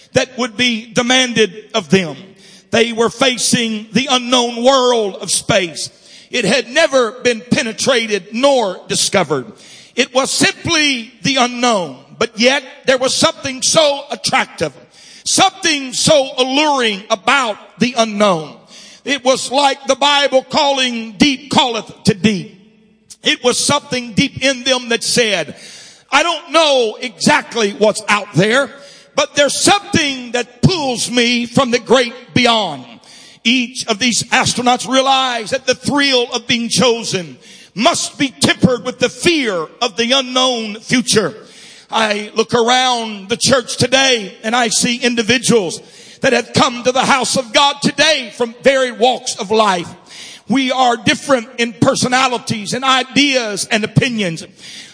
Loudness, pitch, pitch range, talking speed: -14 LUFS, 245 Hz, 225-265 Hz, 140 wpm